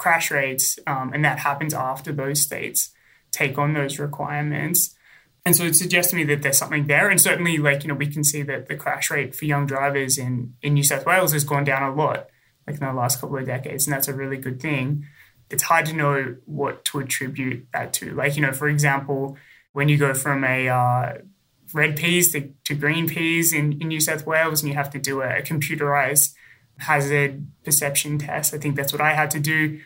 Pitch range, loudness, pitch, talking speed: 140-155 Hz, -21 LUFS, 145 Hz, 225 wpm